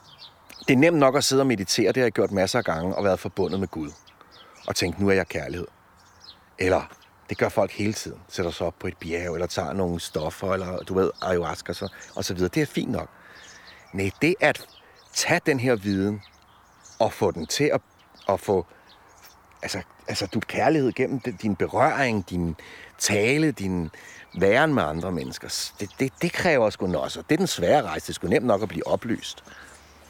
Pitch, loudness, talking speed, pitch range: 95 Hz, -25 LUFS, 205 wpm, 85-125 Hz